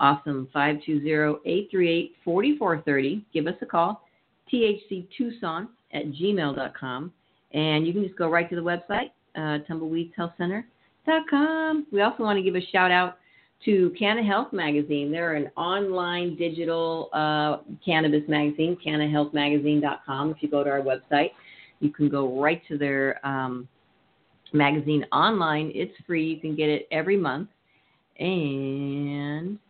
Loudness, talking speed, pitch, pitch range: -25 LUFS, 125 wpm, 160 Hz, 150-185 Hz